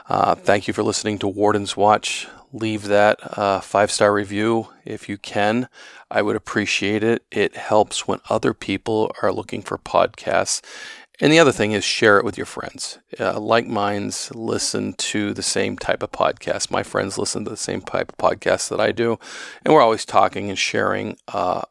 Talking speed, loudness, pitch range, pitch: 190 wpm, -20 LUFS, 100-110 Hz, 105 Hz